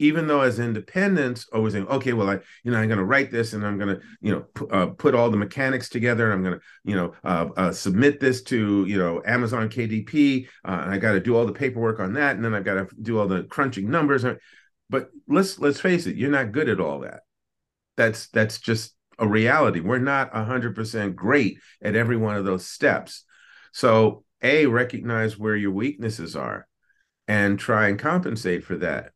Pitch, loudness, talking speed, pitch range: 115 Hz, -23 LUFS, 220 wpm, 105-130 Hz